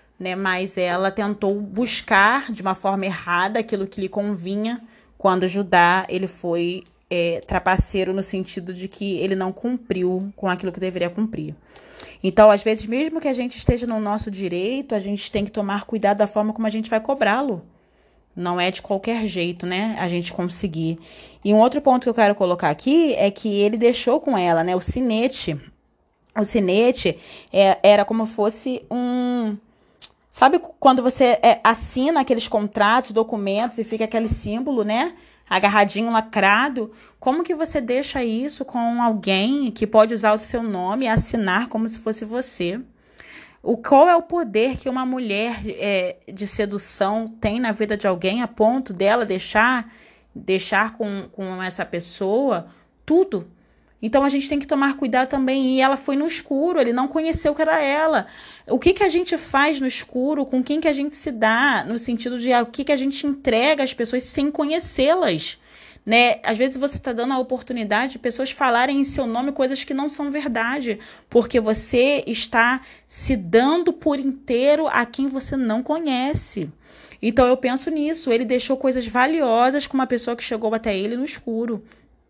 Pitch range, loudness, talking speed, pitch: 205-265 Hz, -21 LUFS, 180 wpm, 230 Hz